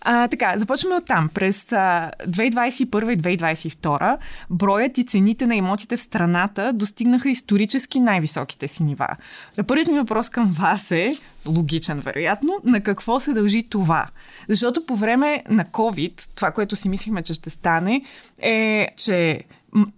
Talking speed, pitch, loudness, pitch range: 150 wpm, 210 Hz, -20 LUFS, 180-240 Hz